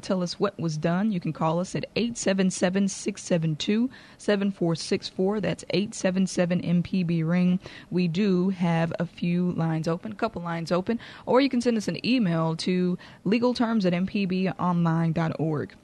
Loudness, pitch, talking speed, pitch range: -26 LUFS, 180 Hz, 150 wpm, 170-205 Hz